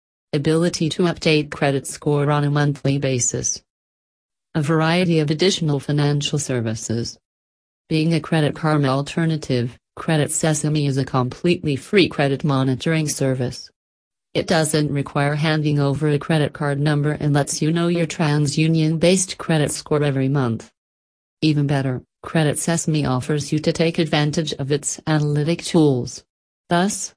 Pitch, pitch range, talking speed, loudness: 150 Hz, 135-160 Hz, 140 wpm, -20 LUFS